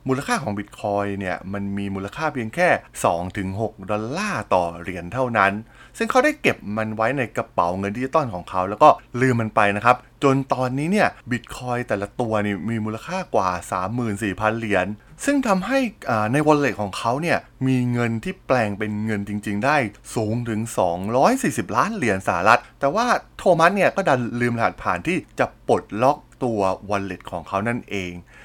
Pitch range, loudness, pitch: 100-130 Hz, -22 LUFS, 110 Hz